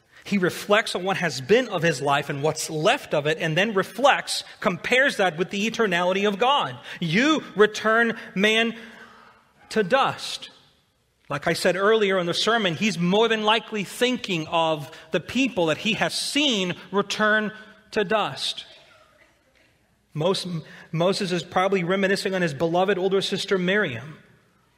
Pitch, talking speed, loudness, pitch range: 195 Hz, 150 wpm, -23 LUFS, 170-215 Hz